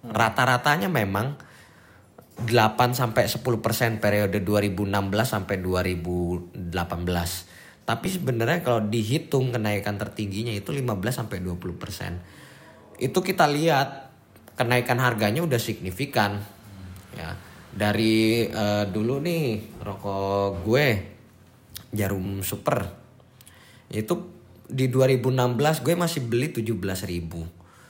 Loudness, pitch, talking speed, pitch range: -25 LUFS, 110 Hz, 90 wpm, 100-125 Hz